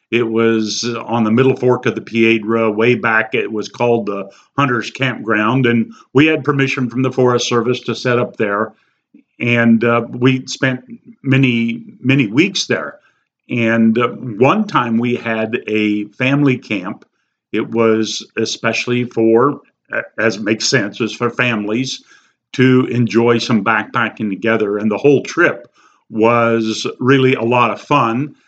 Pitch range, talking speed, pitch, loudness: 110-130 Hz, 150 wpm, 120 Hz, -15 LUFS